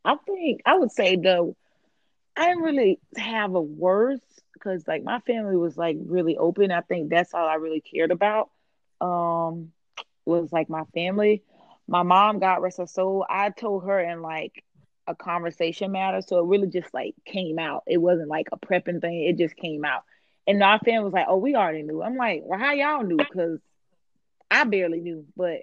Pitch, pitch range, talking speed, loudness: 180 Hz, 170-205 Hz, 195 wpm, -24 LUFS